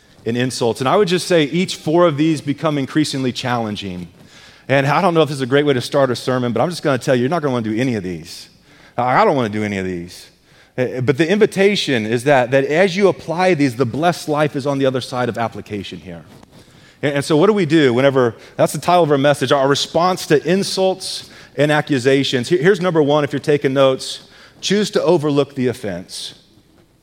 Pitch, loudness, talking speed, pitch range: 140 Hz, -17 LUFS, 225 wpm, 125-160 Hz